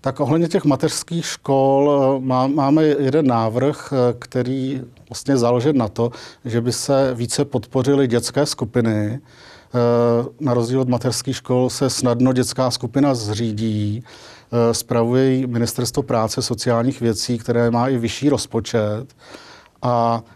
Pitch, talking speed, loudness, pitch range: 125 Hz, 120 wpm, -19 LUFS, 120-135 Hz